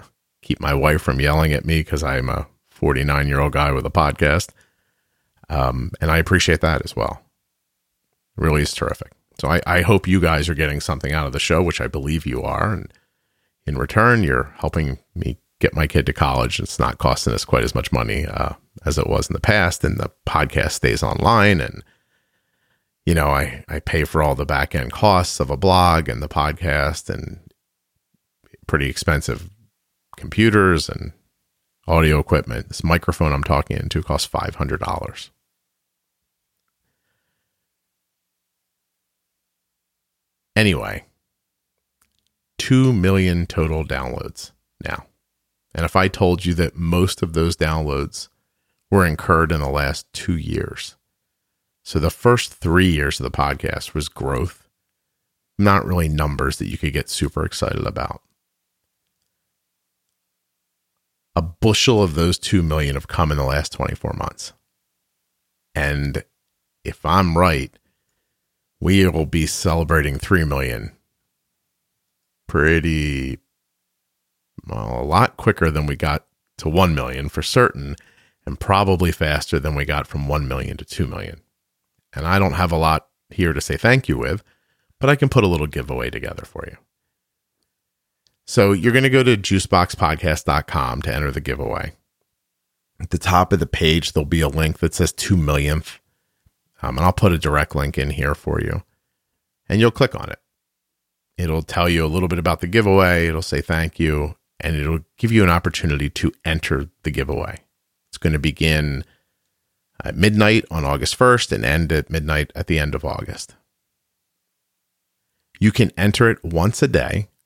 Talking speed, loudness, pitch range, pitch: 160 wpm, -19 LUFS, 70-90 Hz, 80 Hz